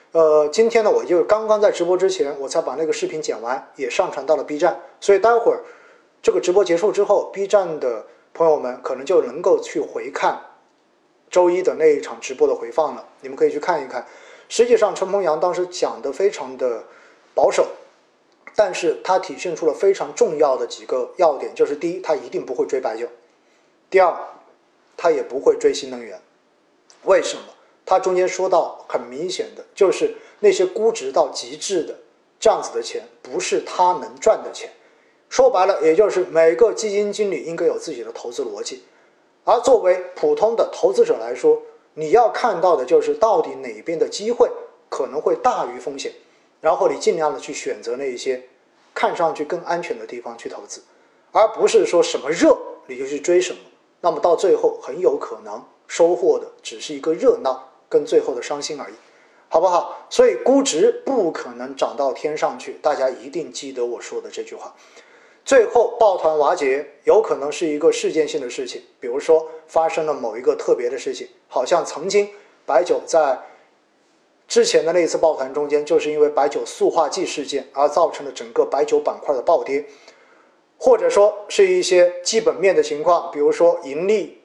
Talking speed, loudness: 280 characters per minute, -19 LUFS